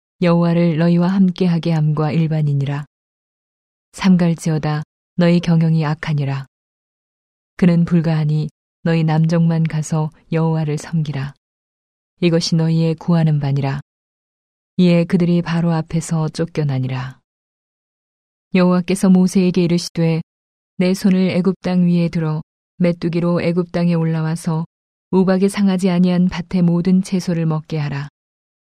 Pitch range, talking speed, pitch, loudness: 155-180 Hz, 280 characters per minute, 165 Hz, -17 LUFS